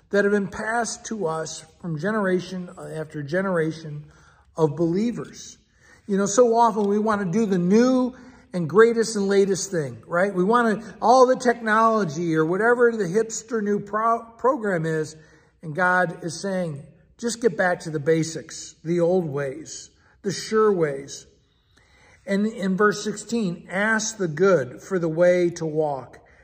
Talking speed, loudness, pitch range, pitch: 160 wpm, -22 LUFS, 165-220 Hz, 195 Hz